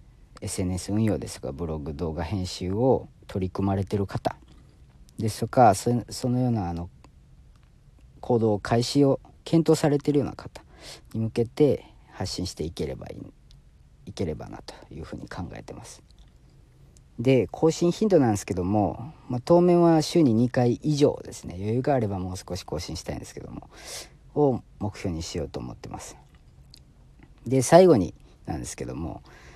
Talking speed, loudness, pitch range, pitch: 310 characters per minute, -25 LUFS, 95-135 Hz, 110 Hz